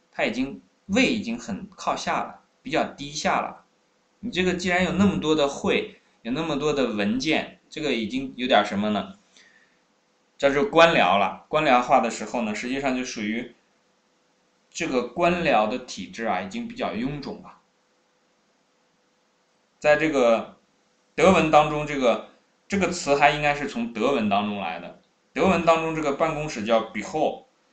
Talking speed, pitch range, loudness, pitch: 245 characters per minute, 140-200 Hz, -23 LUFS, 160 Hz